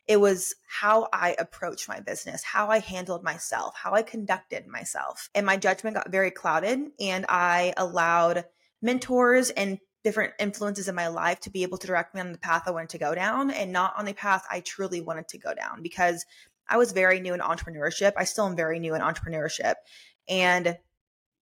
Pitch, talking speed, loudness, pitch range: 185 Hz, 200 wpm, -27 LUFS, 175-205 Hz